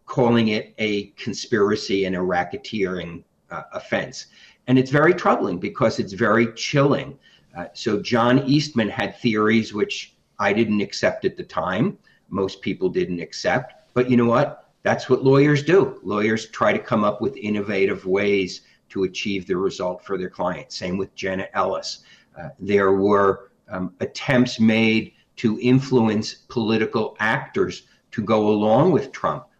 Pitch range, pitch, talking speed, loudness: 100-125 Hz, 110 Hz, 155 wpm, -21 LUFS